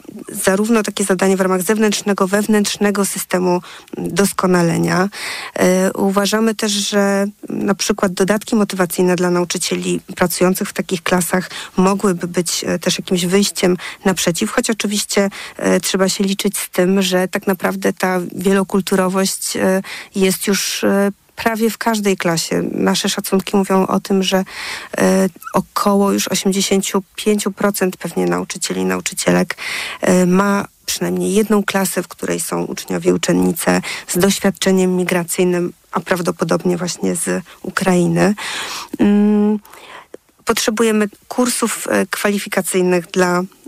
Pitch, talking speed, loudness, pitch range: 190 Hz, 115 wpm, -17 LUFS, 180-205 Hz